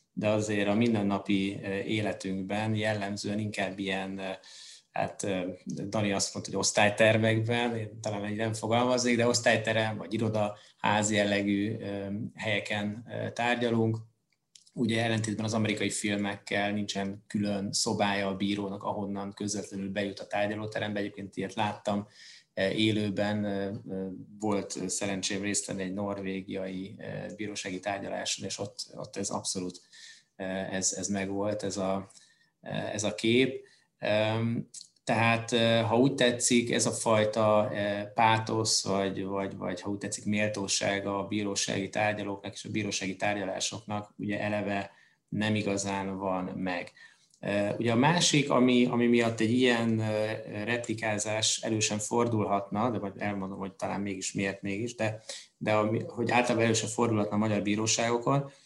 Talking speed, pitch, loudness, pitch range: 125 wpm, 105 Hz, -30 LUFS, 100-110 Hz